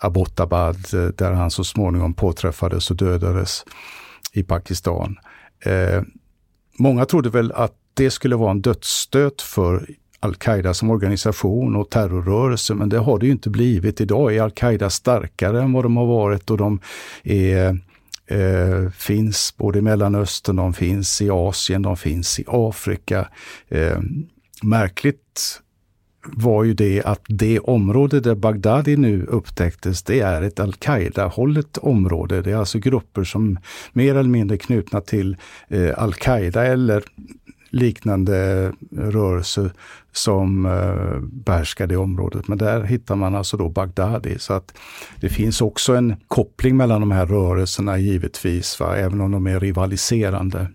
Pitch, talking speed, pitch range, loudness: 100 Hz, 140 wpm, 95-115 Hz, -20 LUFS